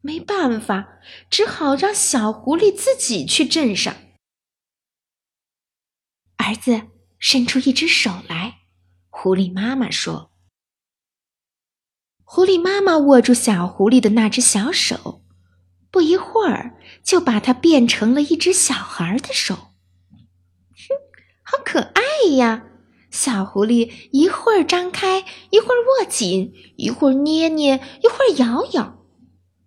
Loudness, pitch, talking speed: -17 LUFS, 250 Hz, 170 characters per minute